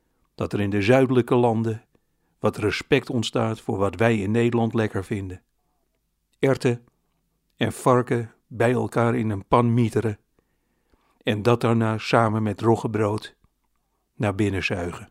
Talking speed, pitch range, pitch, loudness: 135 wpm, 105-120 Hz, 115 Hz, -23 LUFS